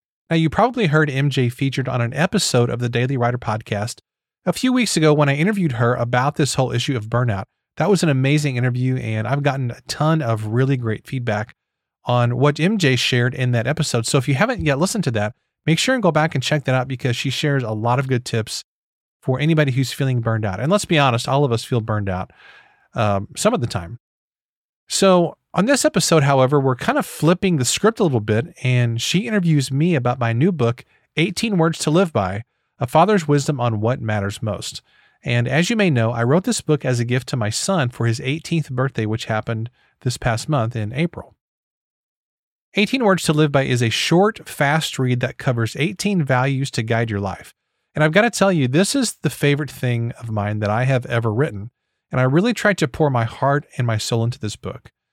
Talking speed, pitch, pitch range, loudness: 225 wpm, 130 Hz, 120-160 Hz, -19 LUFS